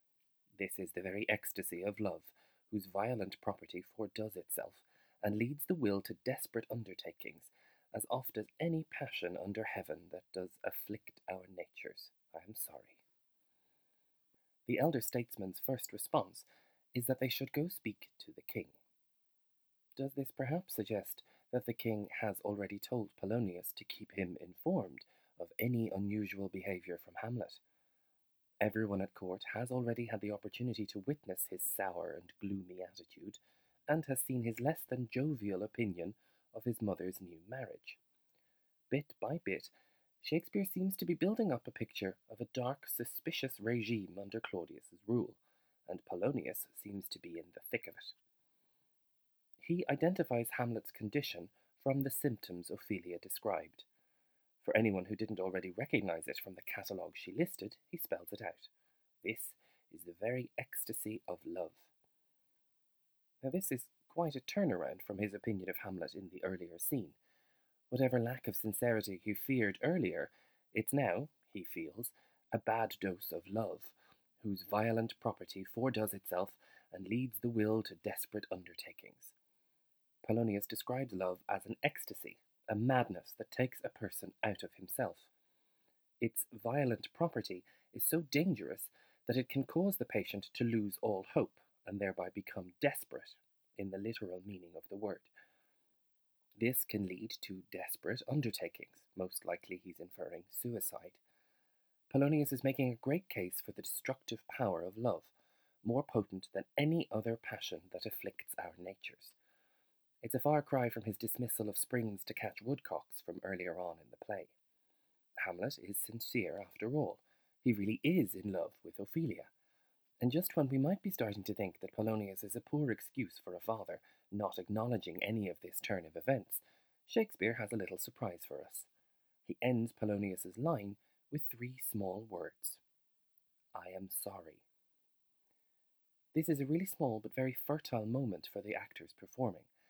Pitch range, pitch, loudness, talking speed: 100-130 Hz, 115 Hz, -40 LUFS, 155 wpm